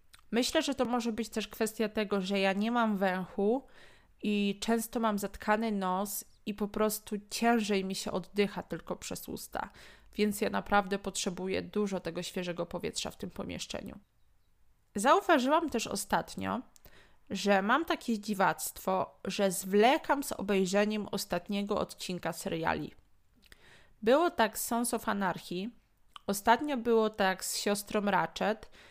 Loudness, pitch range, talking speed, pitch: -32 LUFS, 195-230 Hz, 135 wpm, 210 Hz